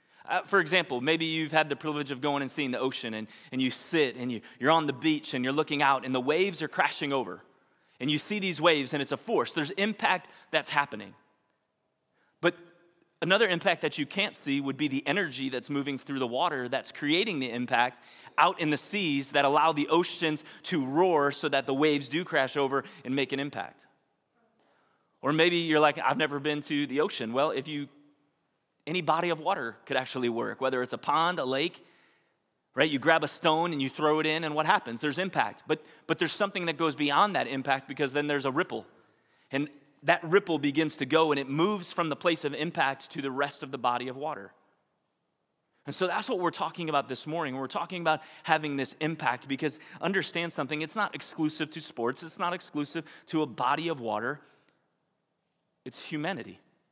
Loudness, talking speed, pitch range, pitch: -29 LUFS, 210 wpm, 135-160 Hz, 150 Hz